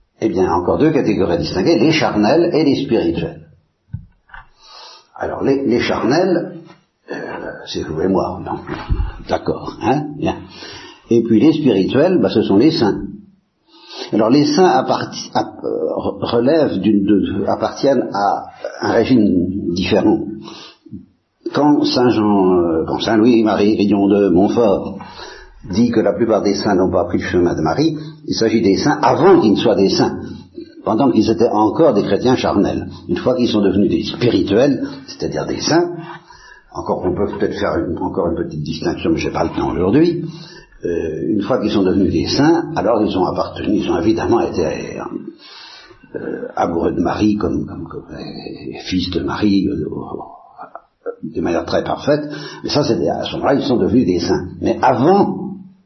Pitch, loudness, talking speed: 120 Hz, -16 LUFS, 170 wpm